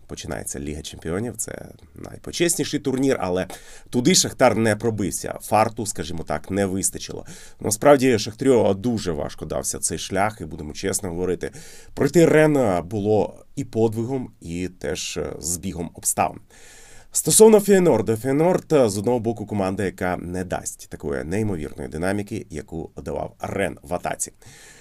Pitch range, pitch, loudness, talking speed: 90-125 Hz, 100 Hz, -22 LUFS, 130 wpm